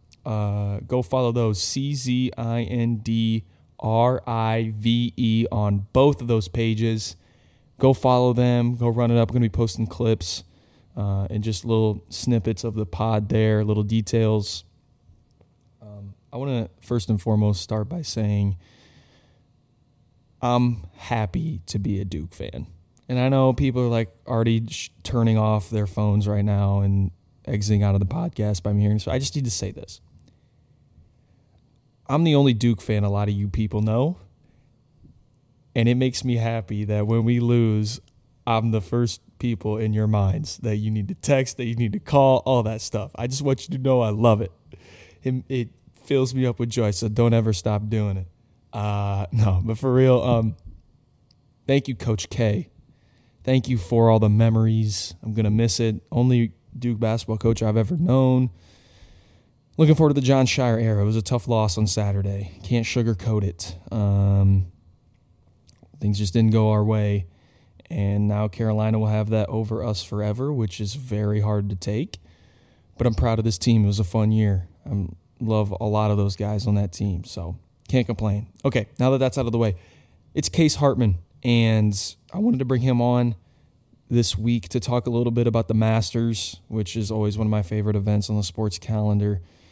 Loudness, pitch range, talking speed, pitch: -23 LUFS, 105-120 Hz, 185 wpm, 110 Hz